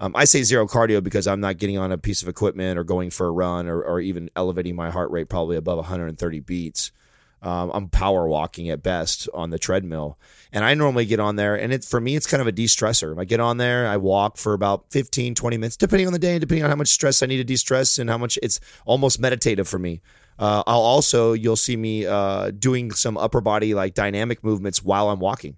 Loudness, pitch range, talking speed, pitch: -21 LUFS, 90-120 Hz, 245 wpm, 105 Hz